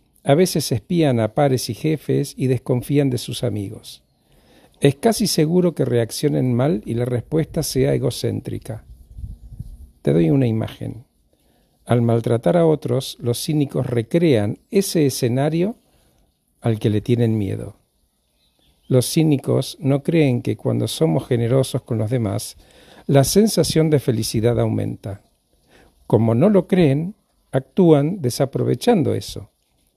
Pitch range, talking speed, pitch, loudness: 115-155 Hz, 130 wpm, 130 Hz, -19 LUFS